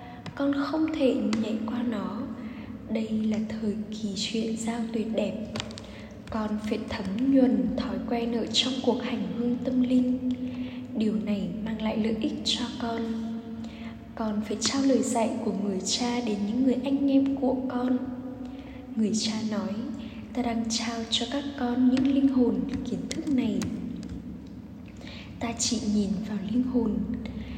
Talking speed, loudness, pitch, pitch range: 155 wpm, -28 LUFS, 235 Hz, 220-250 Hz